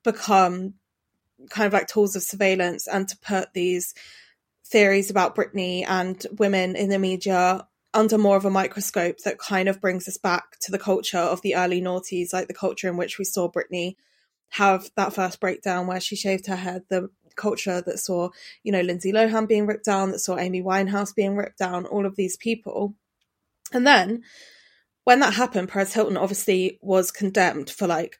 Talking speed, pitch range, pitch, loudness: 185 wpm, 185-205 Hz, 195 Hz, -23 LUFS